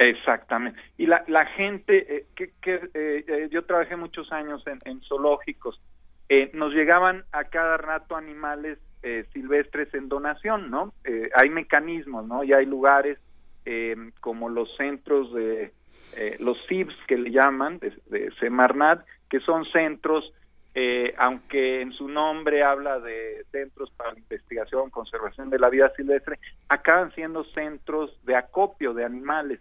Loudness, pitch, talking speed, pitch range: -24 LUFS, 150 Hz, 155 wpm, 130-165 Hz